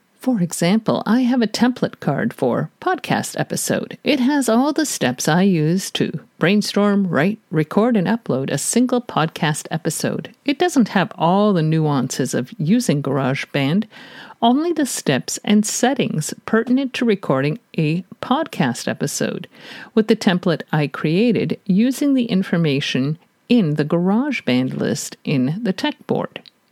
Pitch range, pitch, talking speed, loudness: 160-240 Hz, 210 Hz, 140 wpm, -19 LUFS